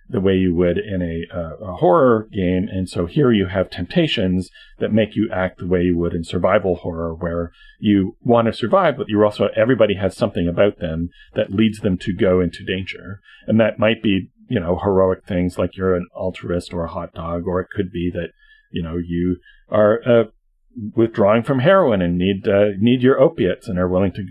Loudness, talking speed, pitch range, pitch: -19 LUFS, 210 wpm, 90-110 Hz, 95 Hz